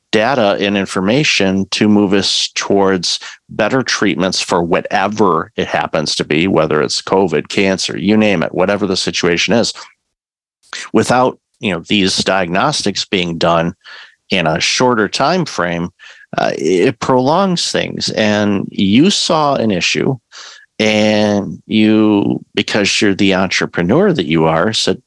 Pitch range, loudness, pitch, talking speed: 95-110 Hz, -14 LUFS, 100 Hz, 135 wpm